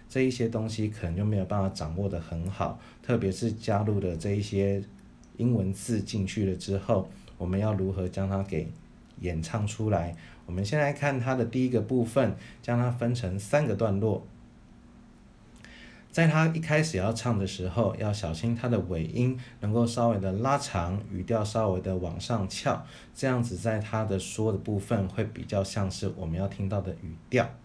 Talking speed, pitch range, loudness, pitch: 265 characters per minute, 95-115 Hz, -29 LUFS, 105 Hz